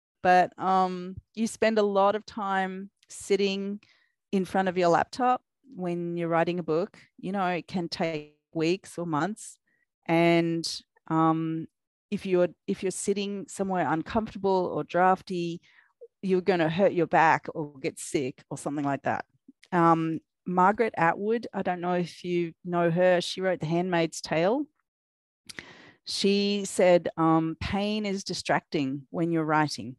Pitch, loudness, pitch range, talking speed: 180 Hz, -27 LUFS, 165-195 Hz, 150 wpm